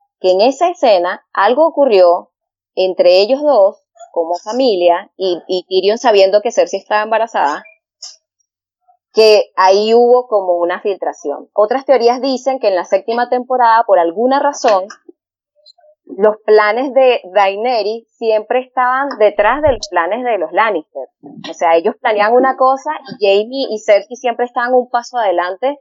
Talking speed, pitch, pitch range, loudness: 150 wpm, 235 Hz, 195-270 Hz, -13 LUFS